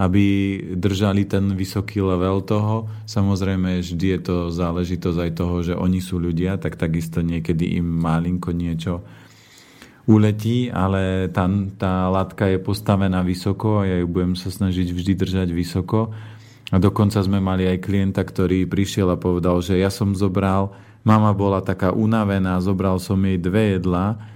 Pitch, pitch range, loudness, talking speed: 95 Hz, 90-100 Hz, -21 LUFS, 155 wpm